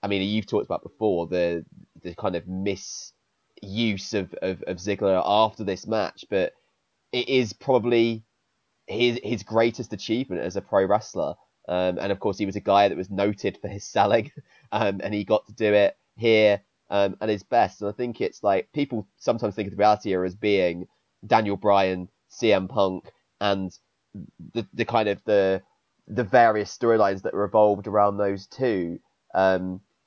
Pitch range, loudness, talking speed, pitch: 95-110 Hz, -24 LUFS, 180 wpm, 105 Hz